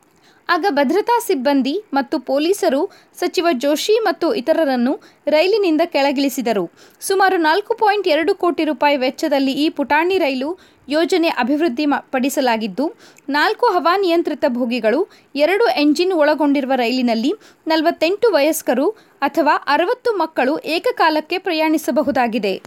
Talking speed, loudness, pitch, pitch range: 105 wpm, -17 LUFS, 315 Hz, 285-360 Hz